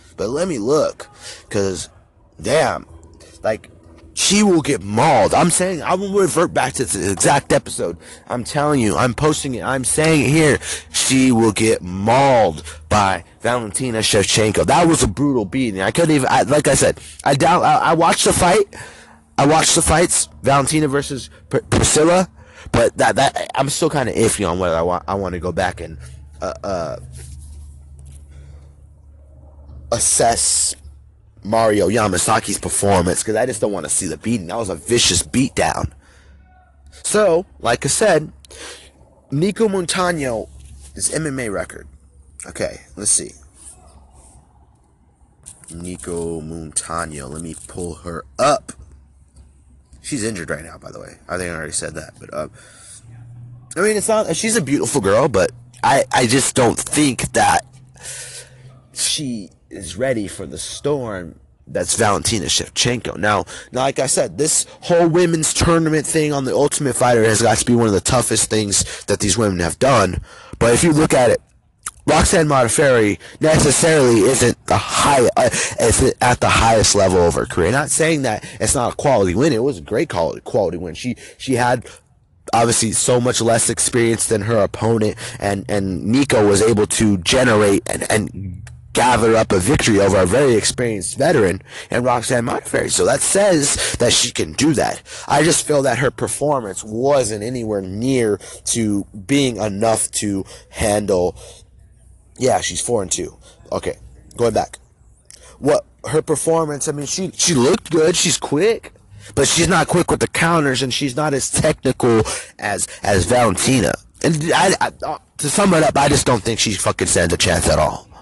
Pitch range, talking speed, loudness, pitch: 85-135 Hz, 165 wpm, -16 LUFS, 110 Hz